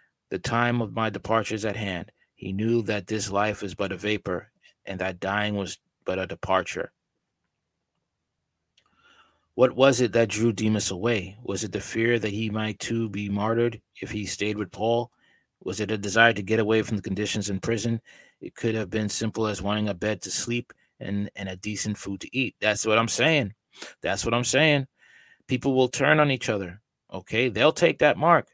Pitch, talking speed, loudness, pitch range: 110 Hz, 200 wpm, -25 LUFS, 100-115 Hz